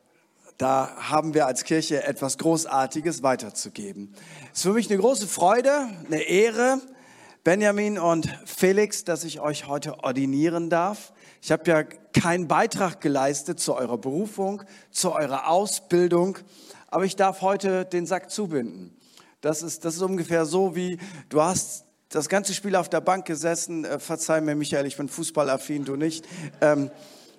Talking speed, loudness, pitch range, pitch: 155 wpm, -24 LUFS, 150-190 Hz, 165 Hz